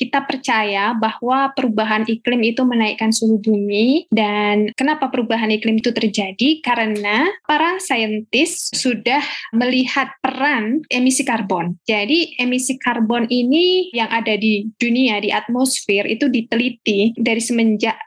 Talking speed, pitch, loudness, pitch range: 125 wpm, 240 Hz, -17 LUFS, 220-265 Hz